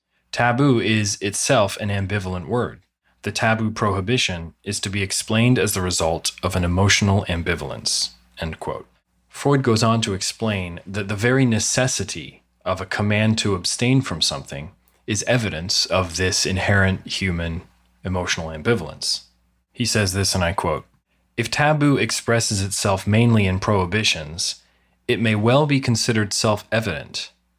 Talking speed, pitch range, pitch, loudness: 145 wpm, 90-115 Hz, 100 Hz, -20 LUFS